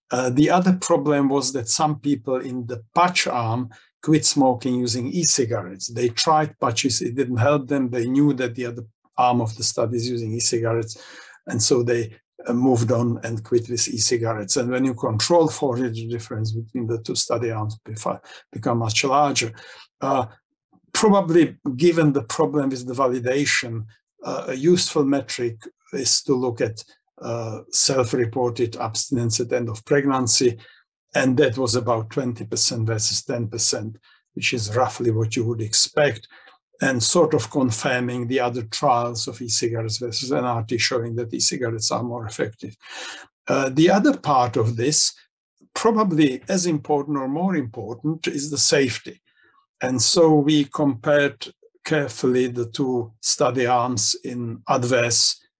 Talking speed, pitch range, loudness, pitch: 155 wpm, 115-145 Hz, -21 LUFS, 125 Hz